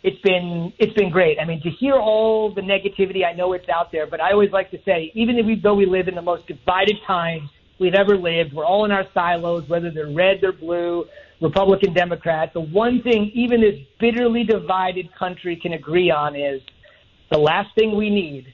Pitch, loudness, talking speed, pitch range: 185 Hz, -19 LUFS, 215 wpm, 170-205 Hz